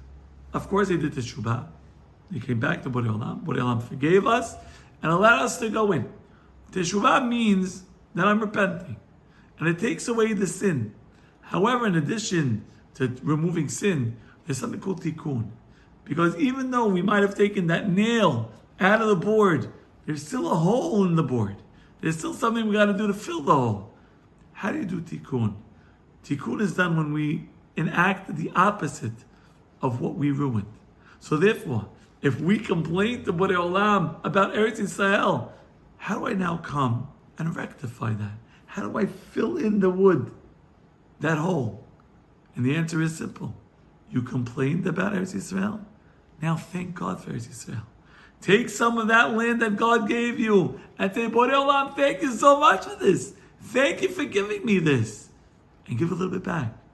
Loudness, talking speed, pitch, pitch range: -24 LUFS, 170 wpm, 180 Hz, 135-210 Hz